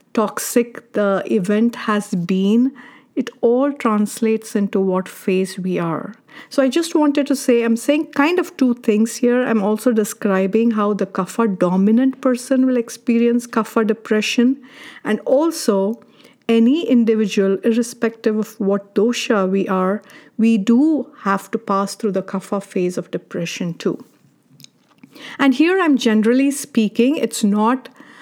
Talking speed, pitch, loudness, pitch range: 140 wpm, 225 Hz, -18 LUFS, 205-250 Hz